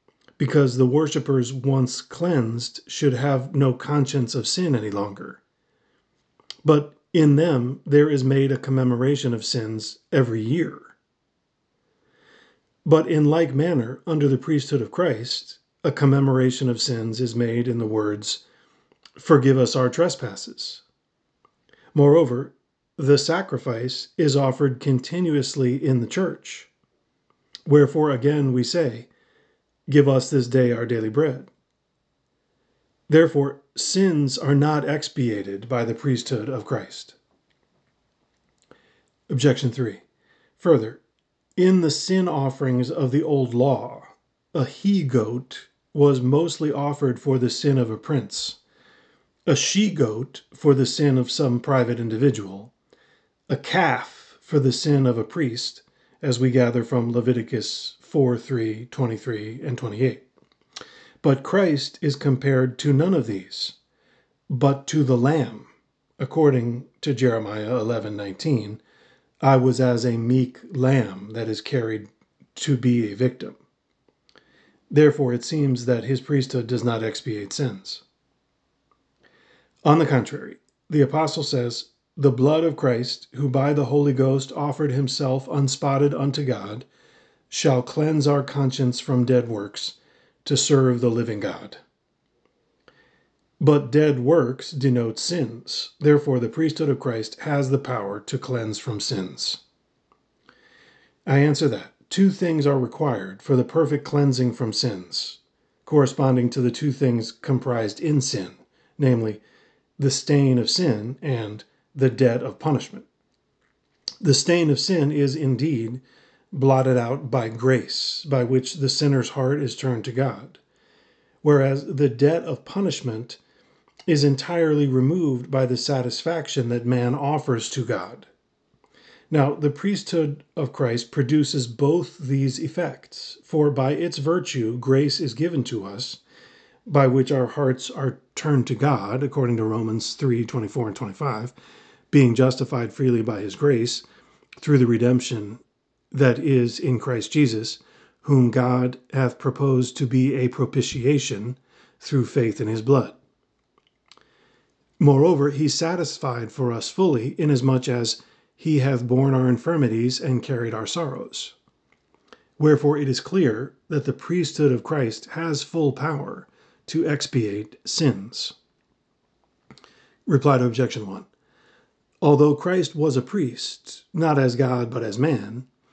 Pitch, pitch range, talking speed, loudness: 135 Hz, 125-145 Hz, 135 wpm, -22 LUFS